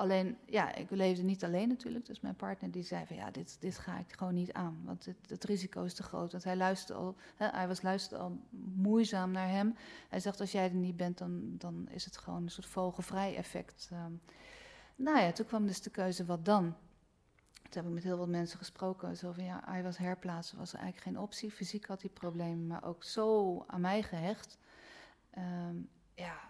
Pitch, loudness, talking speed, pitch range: 185 Hz, -38 LUFS, 215 wpm, 175-205 Hz